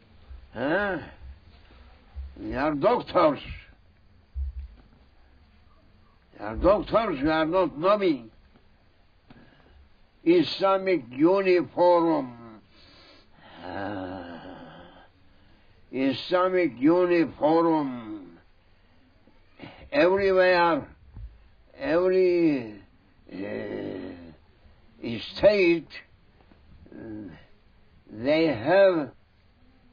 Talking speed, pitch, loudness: 45 wpm, 105 Hz, -24 LUFS